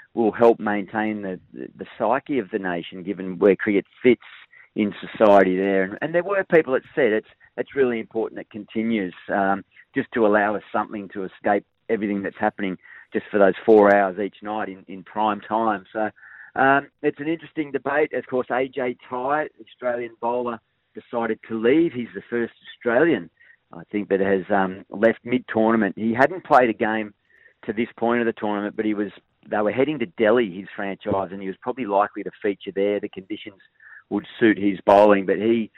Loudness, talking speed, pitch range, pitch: -22 LUFS, 195 wpm, 100-120 Hz, 110 Hz